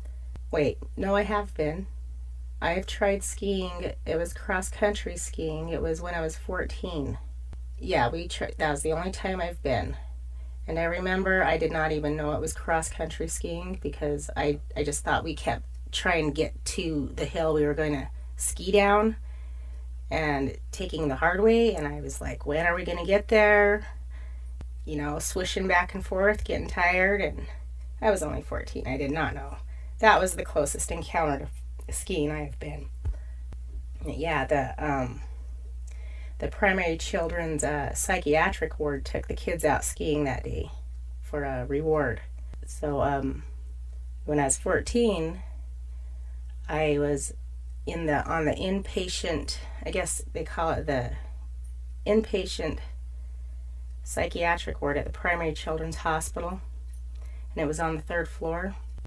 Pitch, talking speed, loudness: 135 Hz, 160 wpm, -28 LUFS